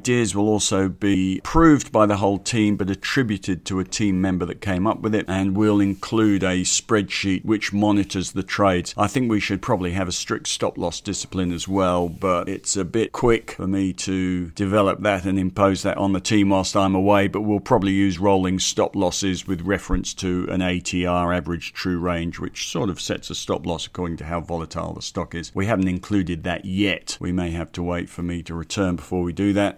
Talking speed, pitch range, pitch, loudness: 220 wpm, 90-100 Hz, 95 Hz, -22 LUFS